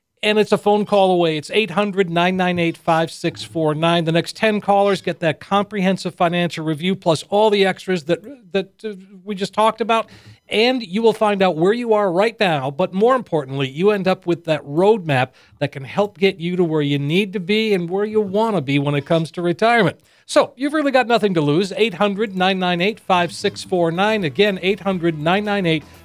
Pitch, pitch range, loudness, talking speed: 190 Hz, 170-210 Hz, -18 LUFS, 180 wpm